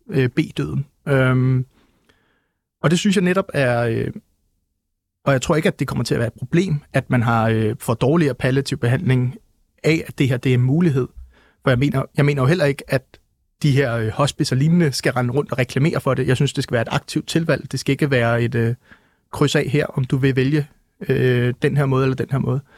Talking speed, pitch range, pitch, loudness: 225 wpm, 125-150 Hz, 135 Hz, -19 LUFS